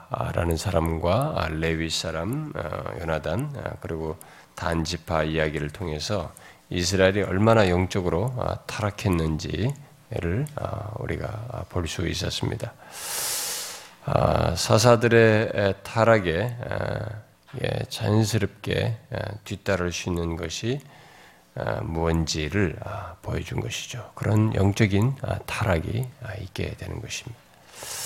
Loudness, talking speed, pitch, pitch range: -25 LUFS, 210 characters per minute, 105 Hz, 85-120 Hz